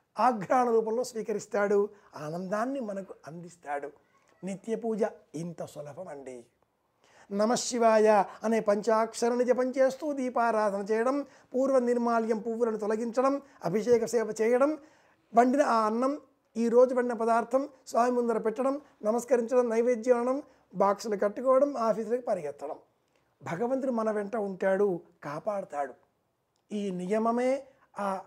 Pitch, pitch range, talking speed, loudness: 225 Hz, 205-250 Hz, 100 wpm, -28 LUFS